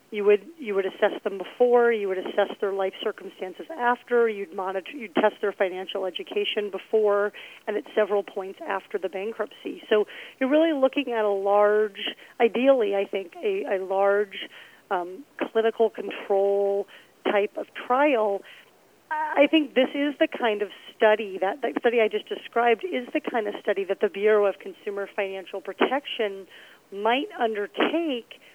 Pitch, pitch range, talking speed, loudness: 210 Hz, 195-245 Hz, 160 wpm, -25 LUFS